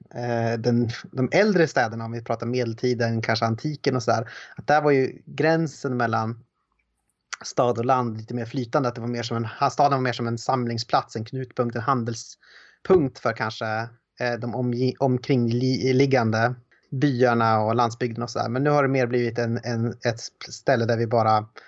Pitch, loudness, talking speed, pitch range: 120 Hz, -24 LUFS, 175 wpm, 115-130 Hz